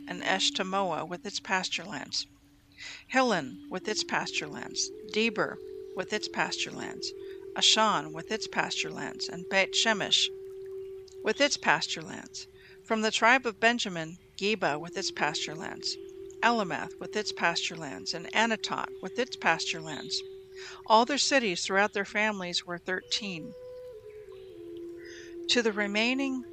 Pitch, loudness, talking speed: 225 Hz, -29 LUFS, 120 wpm